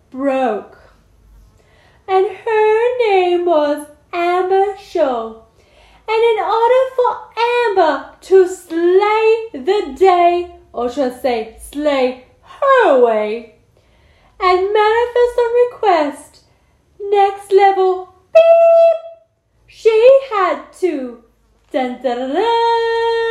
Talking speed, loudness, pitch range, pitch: 95 wpm, -14 LUFS, 285-435 Hz, 365 Hz